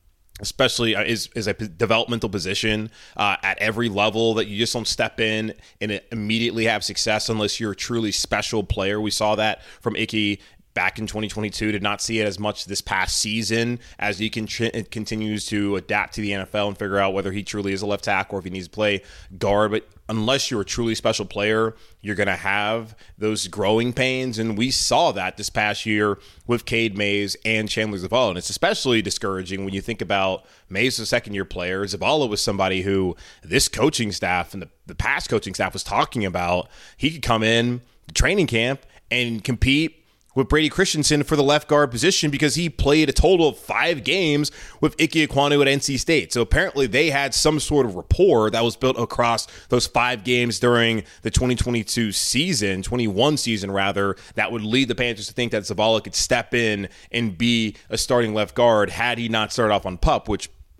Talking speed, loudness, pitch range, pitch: 205 wpm, -21 LUFS, 100-120 Hz, 110 Hz